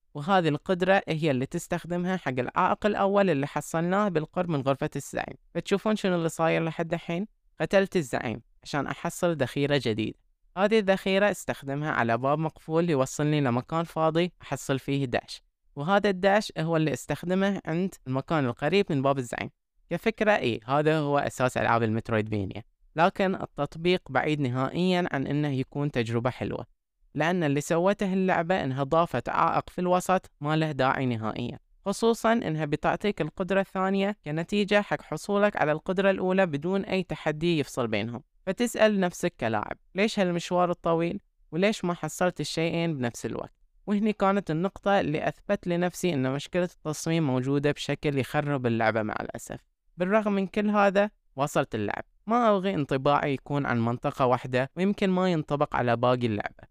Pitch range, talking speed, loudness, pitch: 140-190 Hz, 150 wpm, -27 LUFS, 160 Hz